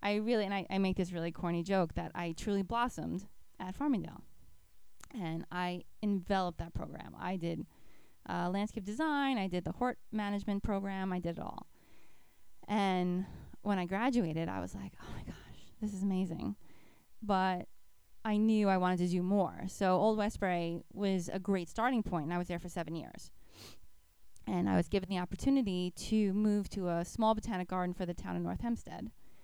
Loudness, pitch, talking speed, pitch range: -35 LUFS, 190 Hz, 185 wpm, 175-210 Hz